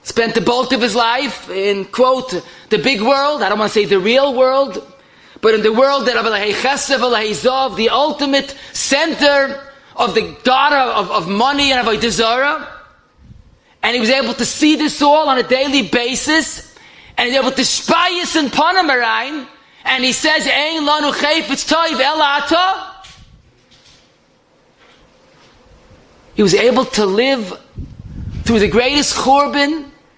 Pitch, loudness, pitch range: 265 Hz, -14 LUFS, 235-285 Hz